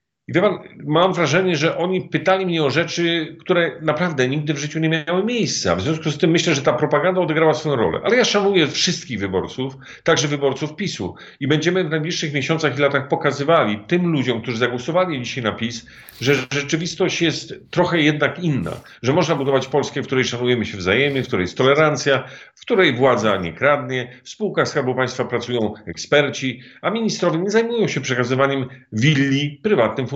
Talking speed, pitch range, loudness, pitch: 180 wpm, 130-170 Hz, -19 LUFS, 150 Hz